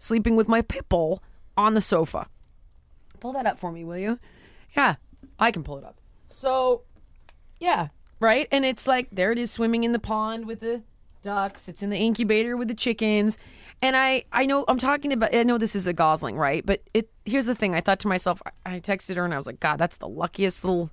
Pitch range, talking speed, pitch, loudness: 180-235 Hz, 225 wpm, 215 Hz, -25 LUFS